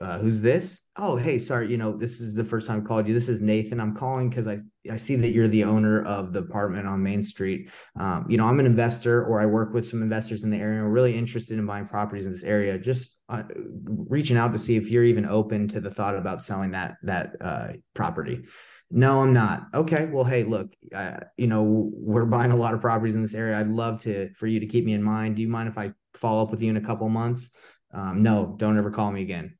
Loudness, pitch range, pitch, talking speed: -25 LUFS, 105-120 Hz, 110 Hz, 255 wpm